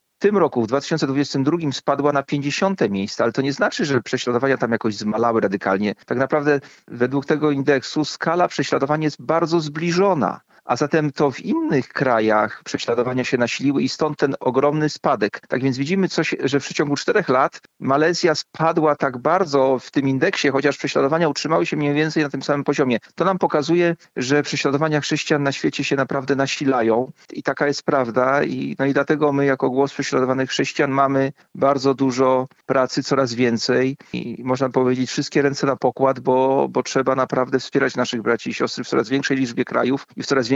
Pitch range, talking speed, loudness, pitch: 130-150 Hz, 185 wpm, -20 LUFS, 140 Hz